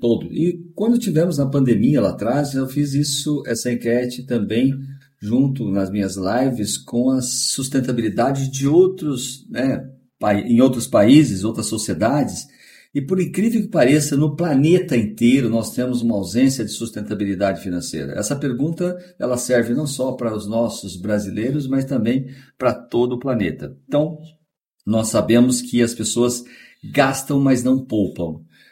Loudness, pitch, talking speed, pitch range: -19 LUFS, 125 Hz, 145 wpm, 115-140 Hz